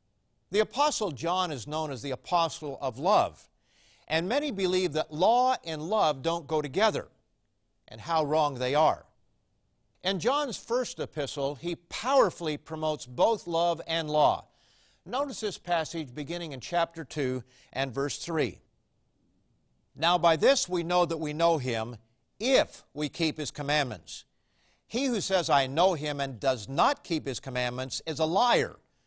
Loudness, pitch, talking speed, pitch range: -28 LUFS, 160 Hz, 155 wpm, 140-175 Hz